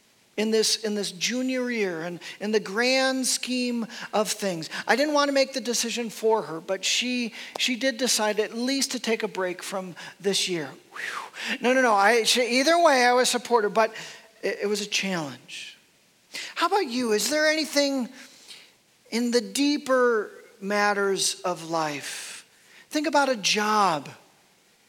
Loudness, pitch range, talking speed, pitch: -24 LUFS, 200-255 Hz, 170 wpm, 225 Hz